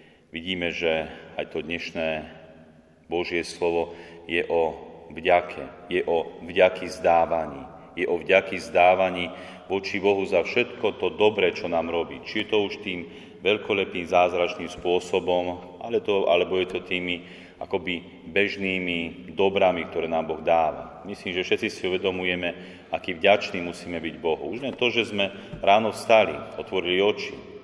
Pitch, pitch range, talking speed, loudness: 90 Hz, 85-95 Hz, 145 wpm, -25 LUFS